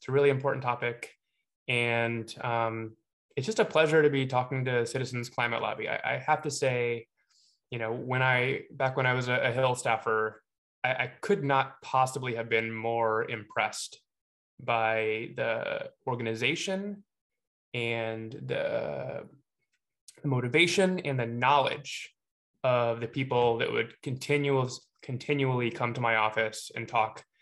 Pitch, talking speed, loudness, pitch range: 125 Hz, 145 wpm, -29 LUFS, 115-135 Hz